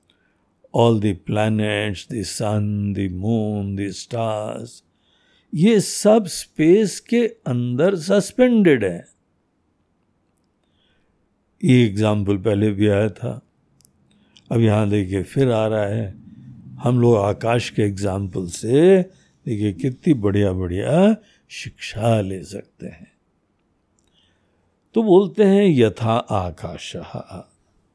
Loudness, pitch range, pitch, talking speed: -19 LUFS, 100-130 Hz, 105 Hz, 90 wpm